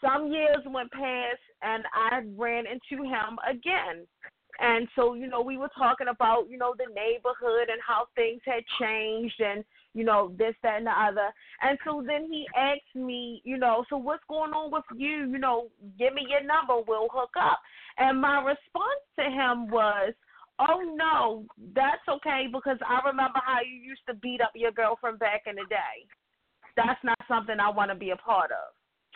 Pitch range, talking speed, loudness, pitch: 230-275 Hz, 190 wpm, -28 LUFS, 250 Hz